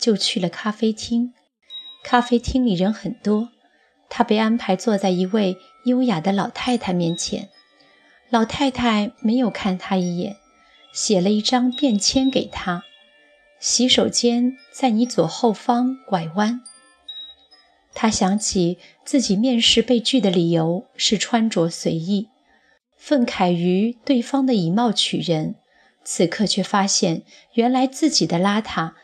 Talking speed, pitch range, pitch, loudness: 195 characters per minute, 190-245 Hz, 220 Hz, -20 LUFS